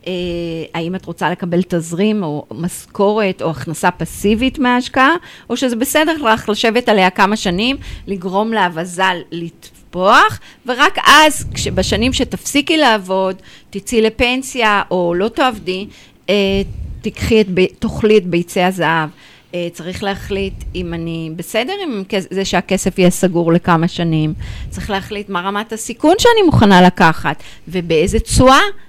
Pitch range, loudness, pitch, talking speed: 175-220 Hz, -15 LUFS, 190 Hz, 130 wpm